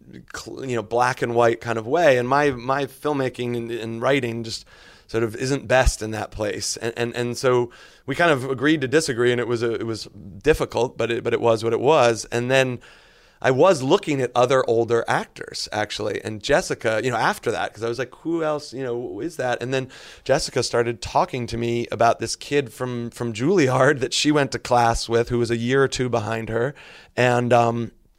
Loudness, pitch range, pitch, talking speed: -22 LUFS, 115-130 Hz, 120 Hz, 220 wpm